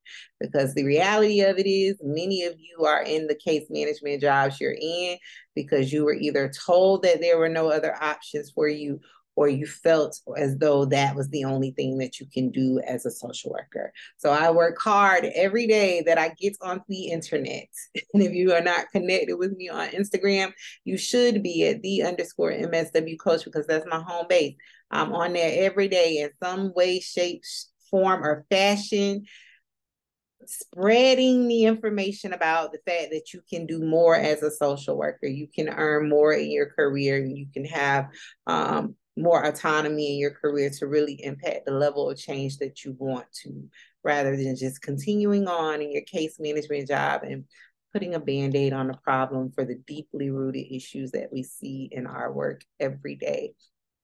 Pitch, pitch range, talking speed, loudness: 160 Hz, 140-190 Hz, 185 wpm, -25 LUFS